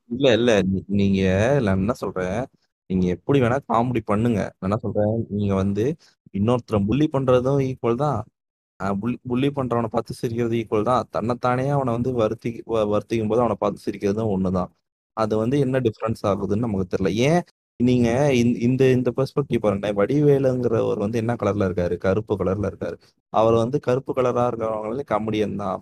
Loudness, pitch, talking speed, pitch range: -22 LUFS, 115 Hz, 150 wpm, 100-125 Hz